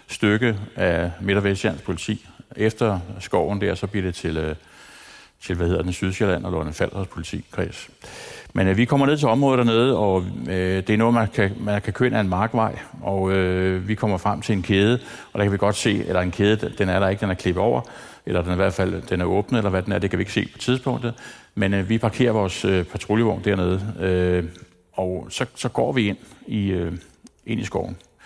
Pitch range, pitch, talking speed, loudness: 90-110 Hz, 100 Hz, 230 wpm, -22 LUFS